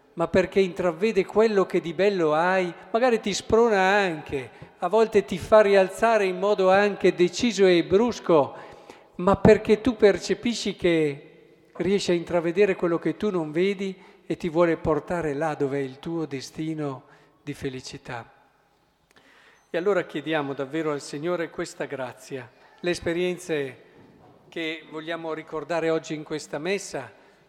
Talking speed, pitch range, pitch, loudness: 140 wpm, 155-195 Hz, 175 Hz, -24 LUFS